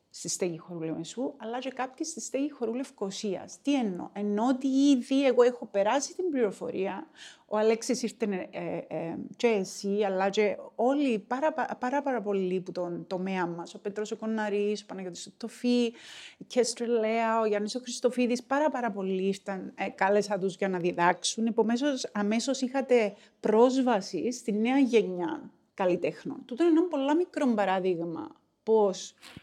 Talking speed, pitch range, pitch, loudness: 155 wpm, 195-255 Hz, 225 Hz, -29 LUFS